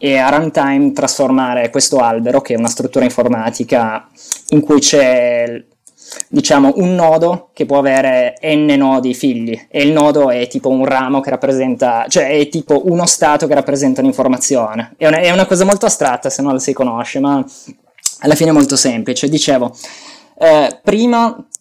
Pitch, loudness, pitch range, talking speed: 140 Hz, -12 LUFS, 130-160 Hz, 170 wpm